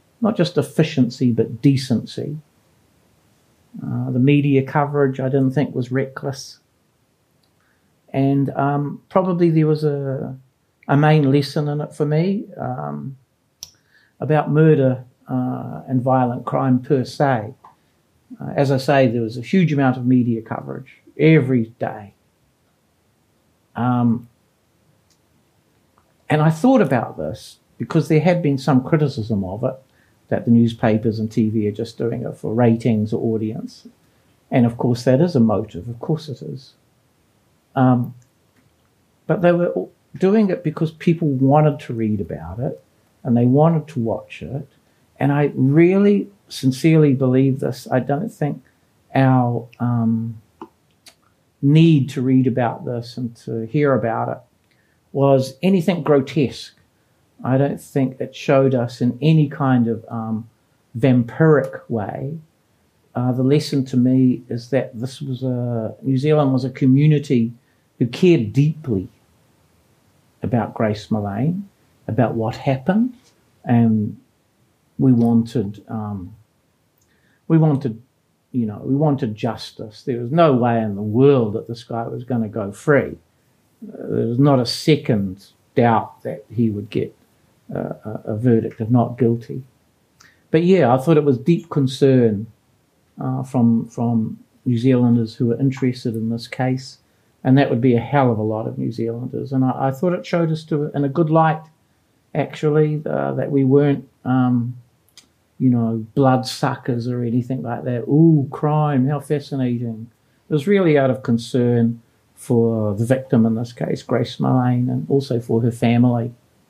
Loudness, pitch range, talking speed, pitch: -19 LUFS, 115-145 Hz, 150 wpm, 130 Hz